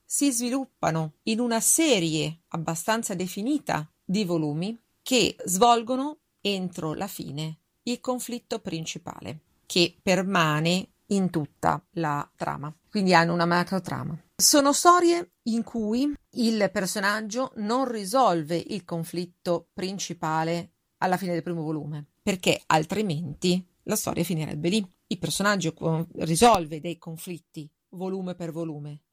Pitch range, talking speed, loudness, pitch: 165-220 Hz, 120 wpm, -26 LUFS, 180 Hz